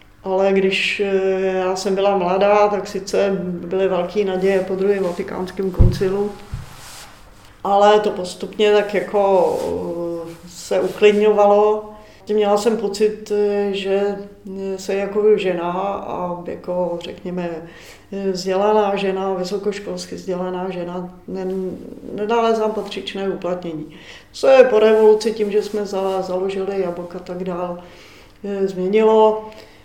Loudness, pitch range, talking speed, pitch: -19 LUFS, 180-205 Hz, 115 wpm, 195 Hz